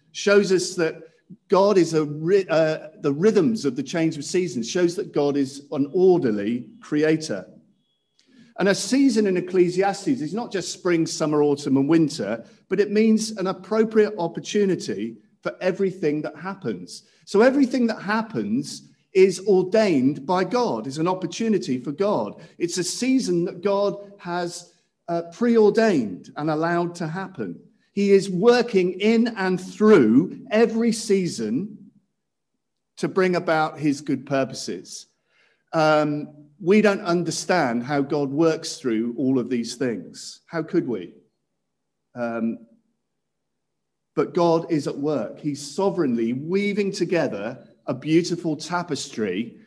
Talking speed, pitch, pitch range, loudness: 135 wpm, 180 Hz, 155-210 Hz, -22 LUFS